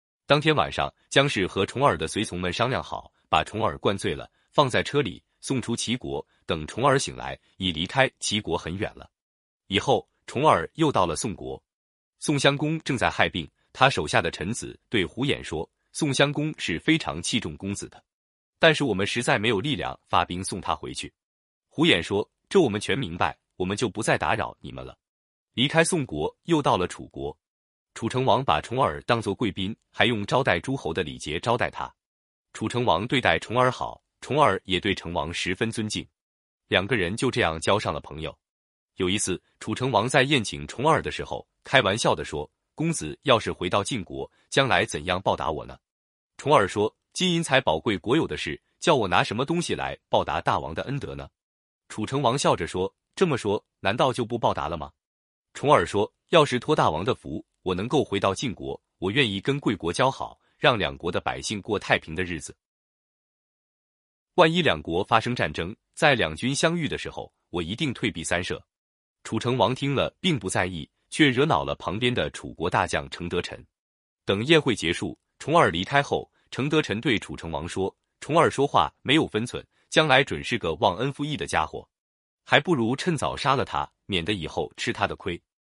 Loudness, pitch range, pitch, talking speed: -25 LUFS, 90-140 Hz, 115 Hz, 275 characters per minute